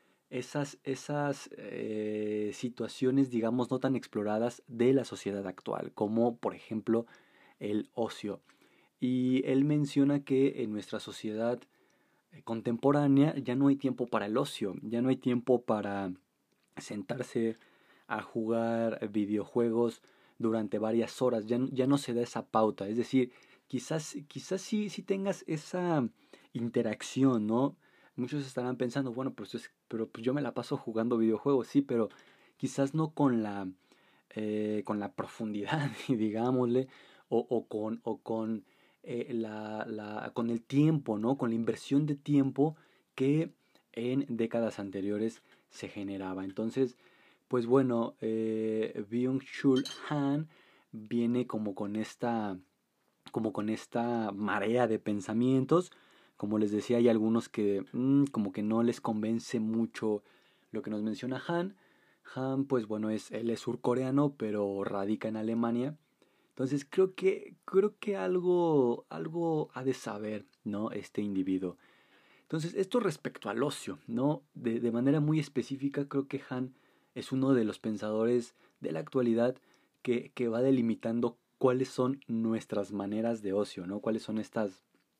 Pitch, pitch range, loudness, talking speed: 120 Hz, 110-135 Hz, -32 LUFS, 140 wpm